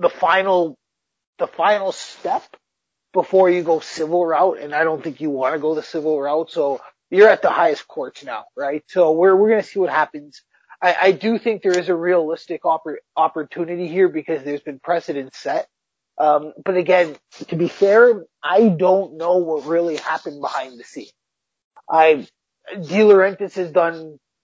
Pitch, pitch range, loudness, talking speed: 170 Hz, 155-185 Hz, -18 LUFS, 170 wpm